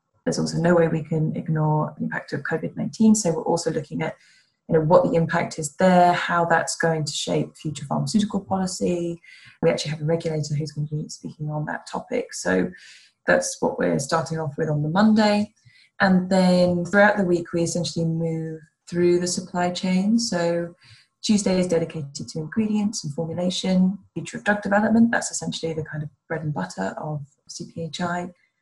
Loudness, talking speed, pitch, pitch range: -23 LUFS, 185 wpm, 170 Hz, 160-185 Hz